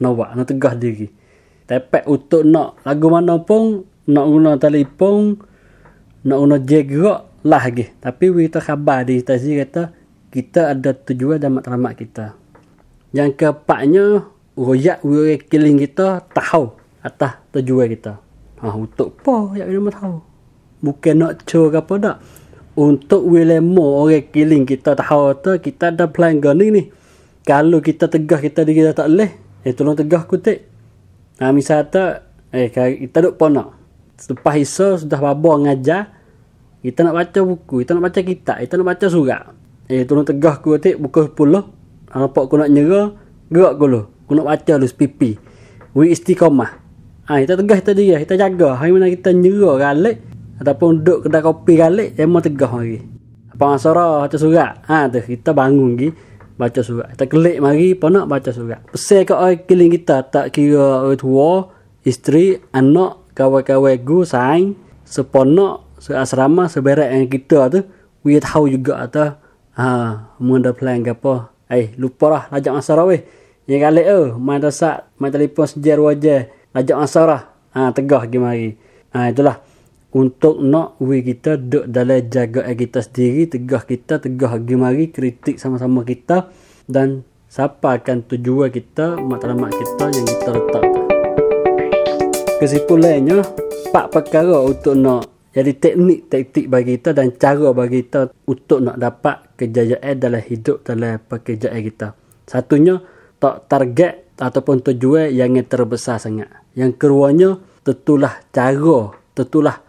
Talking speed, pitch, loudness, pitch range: 155 wpm, 140 Hz, -15 LUFS, 125-165 Hz